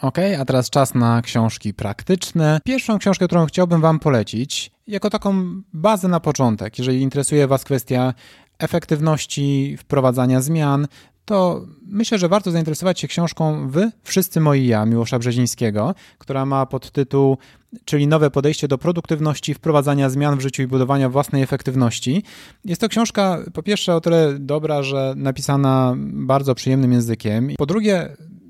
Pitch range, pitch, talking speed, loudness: 130-170 Hz, 145 Hz, 145 wpm, -19 LUFS